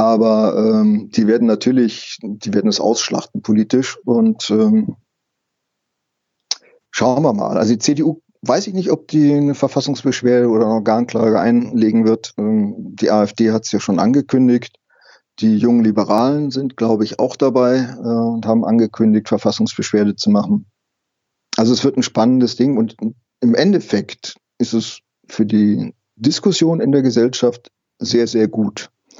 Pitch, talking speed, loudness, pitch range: 120 Hz, 150 wpm, -16 LUFS, 110-145 Hz